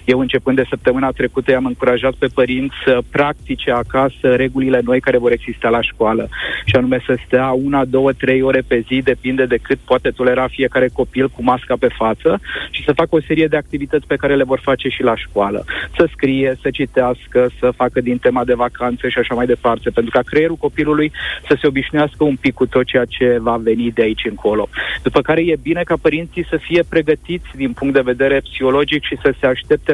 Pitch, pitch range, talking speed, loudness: 130 Hz, 125-145 Hz, 210 wpm, -16 LUFS